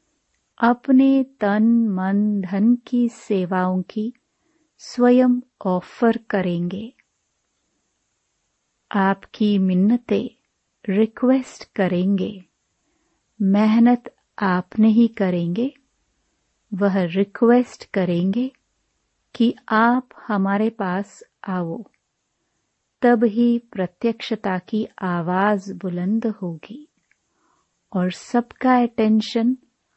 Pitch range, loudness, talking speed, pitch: 195-245 Hz, -20 LUFS, 70 wpm, 220 Hz